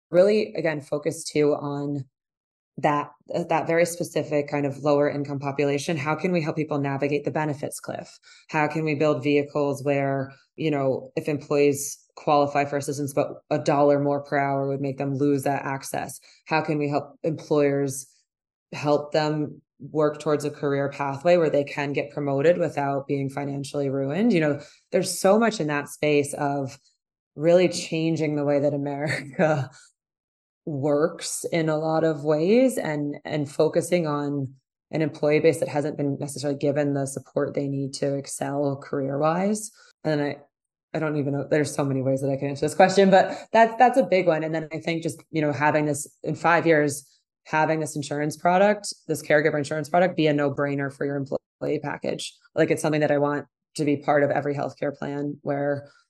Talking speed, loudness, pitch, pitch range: 185 wpm, -24 LUFS, 145 Hz, 140-160 Hz